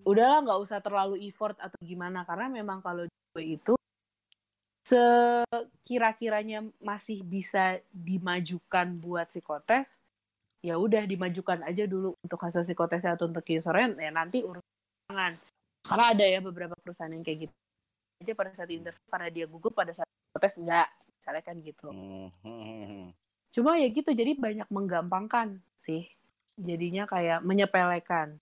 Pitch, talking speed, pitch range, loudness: 180 Hz, 135 wpm, 170-210 Hz, -30 LUFS